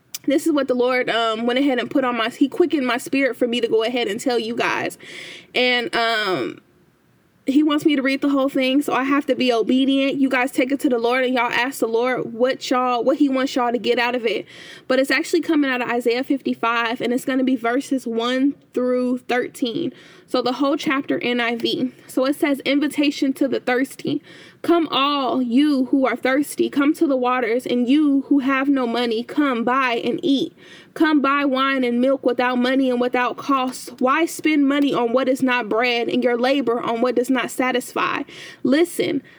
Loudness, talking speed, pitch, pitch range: -20 LUFS, 215 wpm, 260 Hz, 245-280 Hz